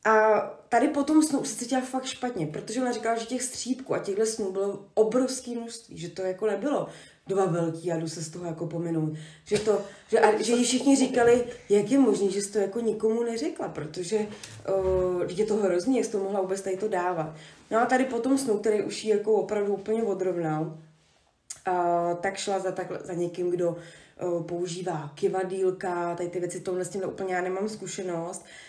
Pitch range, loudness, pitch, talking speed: 180-225 Hz, -27 LUFS, 200 Hz, 195 wpm